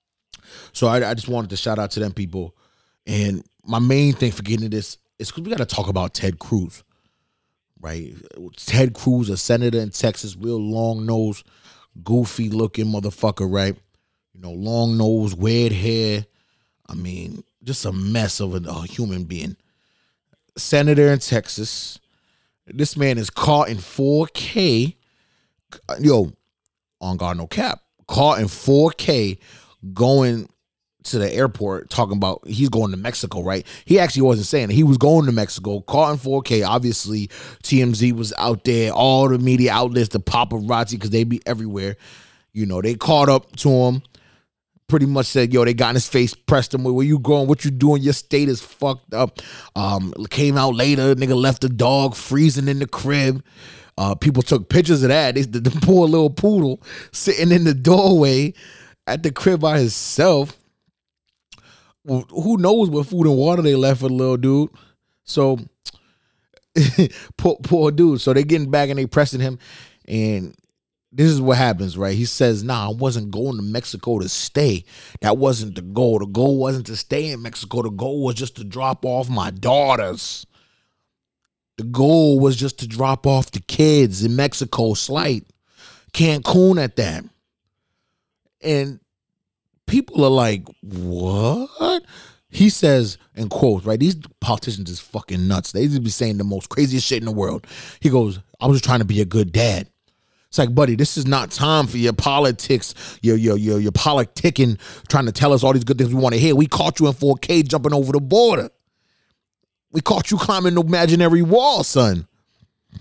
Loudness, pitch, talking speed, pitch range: -18 LUFS, 125 Hz, 175 wpm, 110-140 Hz